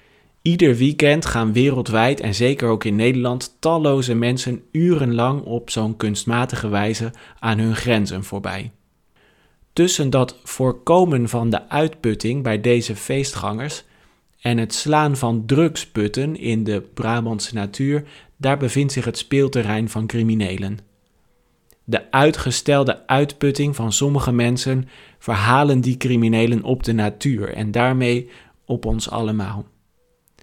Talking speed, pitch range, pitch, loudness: 120 wpm, 110-135 Hz, 120 Hz, -19 LUFS